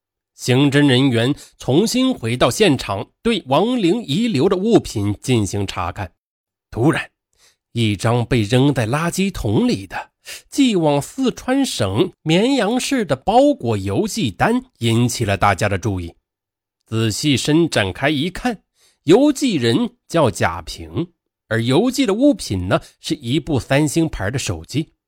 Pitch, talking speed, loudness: 140 Hz, 205 characters per minute, -18 LUFS